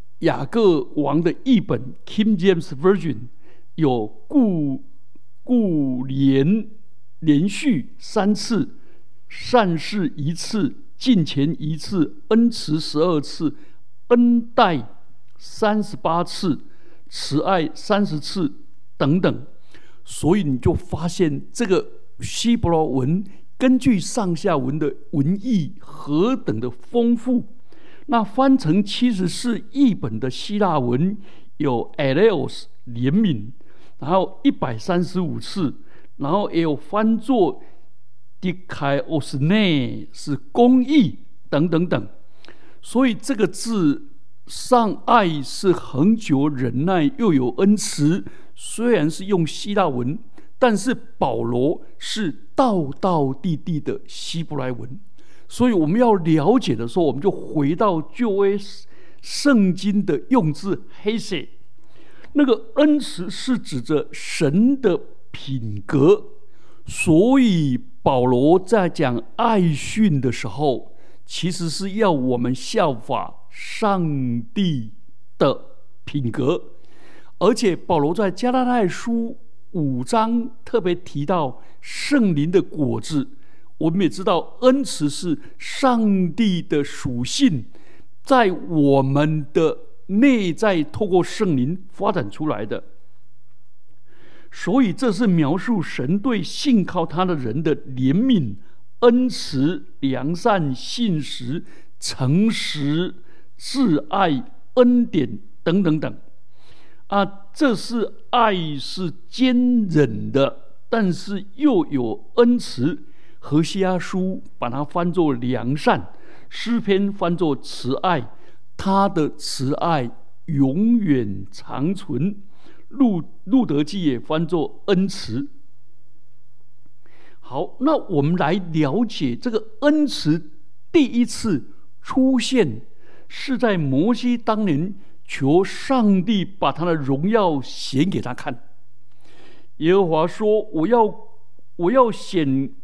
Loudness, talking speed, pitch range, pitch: -20 LUFS, 165 characters per minute, 140-220 Hz, 175 Hz